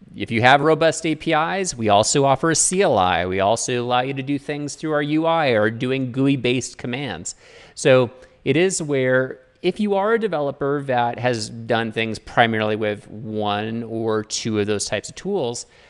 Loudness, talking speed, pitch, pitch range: -20 LUFS, 180 wpm, 130 Hz, 115-155 Hz